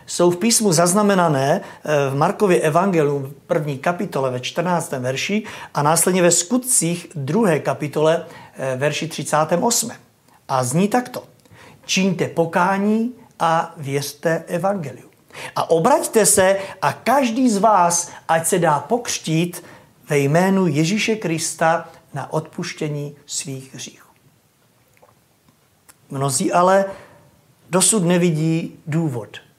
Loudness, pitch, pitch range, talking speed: -19 LUFS, 165 Hz, 145-195 Hz, 105 wpm